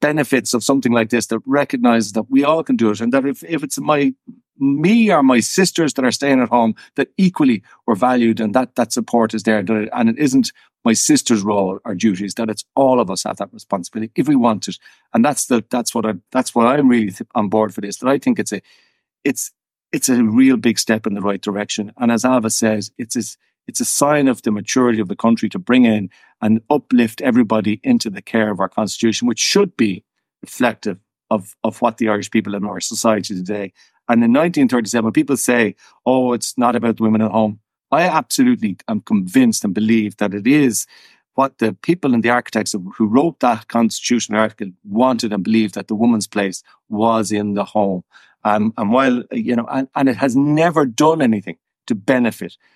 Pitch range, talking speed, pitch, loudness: 110-140 Hz, 215 wpm, 115 Hz, -17 LUFS